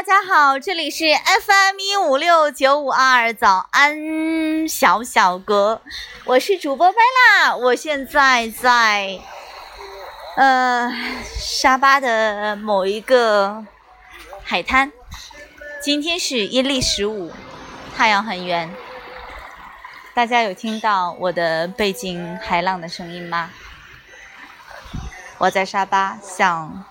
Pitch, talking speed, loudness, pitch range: 250 Hz, 155 characters per minute, -17 LUFS, 200-295 Hz